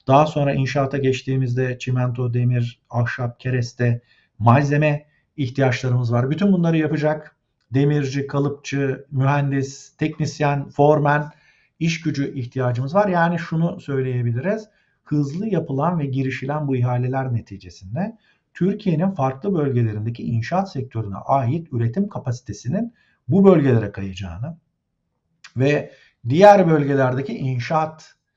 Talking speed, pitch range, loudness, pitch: 100 wpm, 125-155 Hz, -21 LUFS, 140 Hz